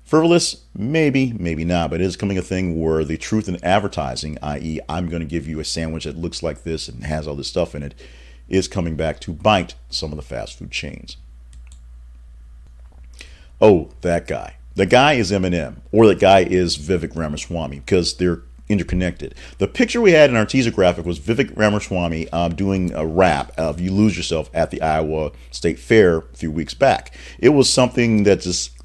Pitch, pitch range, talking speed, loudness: 85 Hz, 70-95 Hz, 195 wpm, -19 LUFS